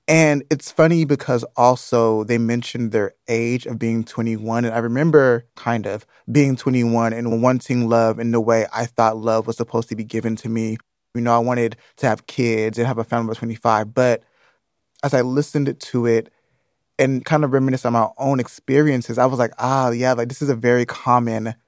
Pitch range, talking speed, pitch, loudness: 115-130 Hz, 200 wpm, 120 Hz, -19 LUFS